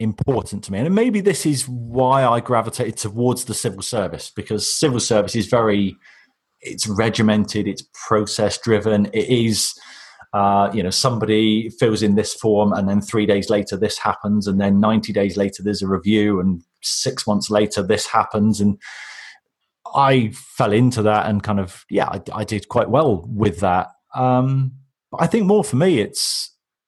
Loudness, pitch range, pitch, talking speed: -19 LUFS, 100-120 Hz, 105 Hz, 175 wpm